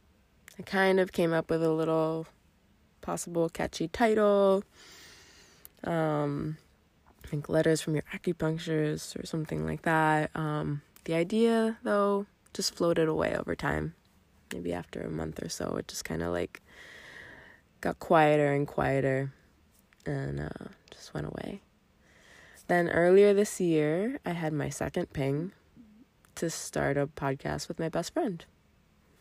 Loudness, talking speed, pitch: -30 LUFS, 140 wpm, 155 Hz